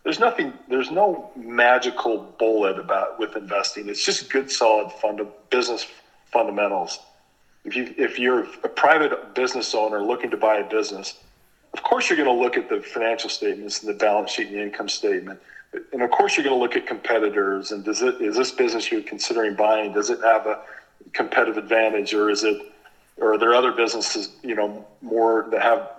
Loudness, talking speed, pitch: -22 LUFS, 190 wpm, 115 Hz